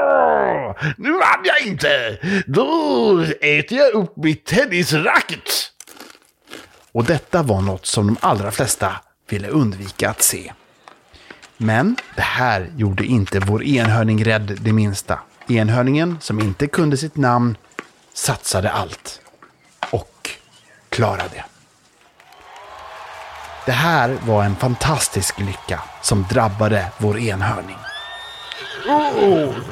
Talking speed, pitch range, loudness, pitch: 110 wpm, 105-155 Hz, -18 LUFS, 120 Hz